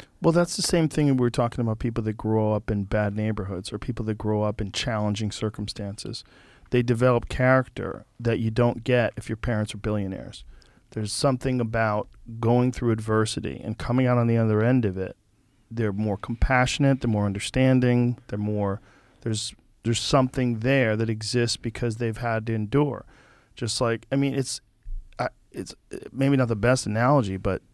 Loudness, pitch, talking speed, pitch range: -25 LUFS, 115 Hz, 180 wpm, 105-125 Hz